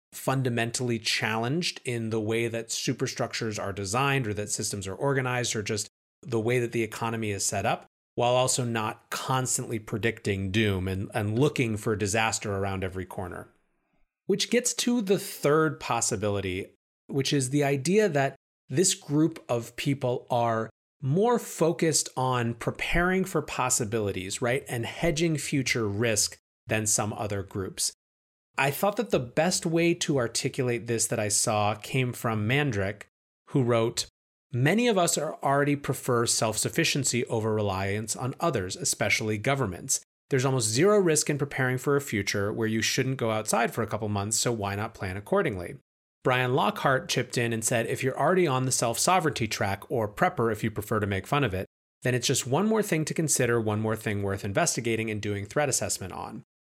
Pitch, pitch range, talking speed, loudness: 120 Hz, 110-140 Hz, 175 wpm, -27 LUFS